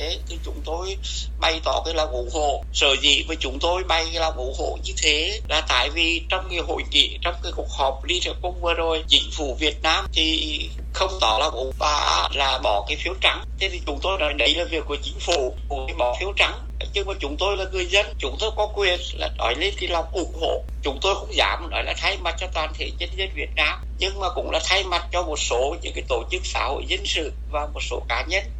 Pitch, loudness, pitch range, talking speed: 165 Hz, -22 LUFS, 140-190 Hz, 255 wpm